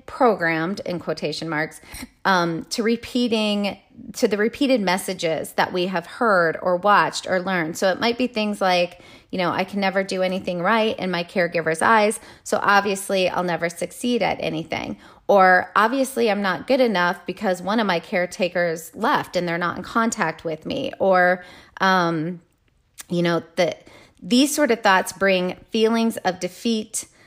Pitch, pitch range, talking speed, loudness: 185 Hz, 175-220 Hz, 165 wpm, -21 LUFS